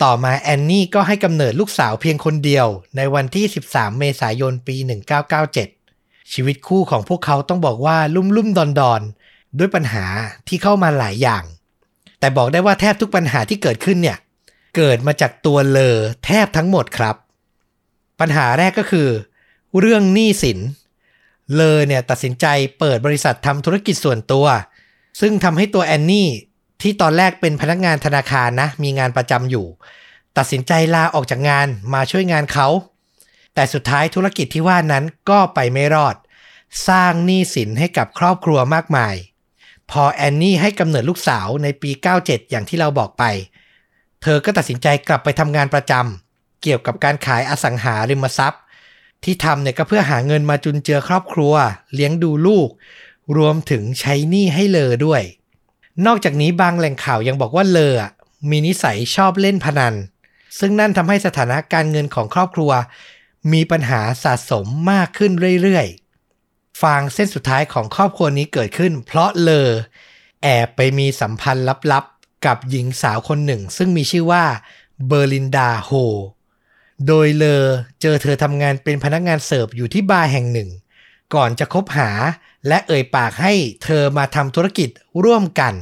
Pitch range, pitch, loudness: 130-175 Hz, 145 Hz, -16 LUFS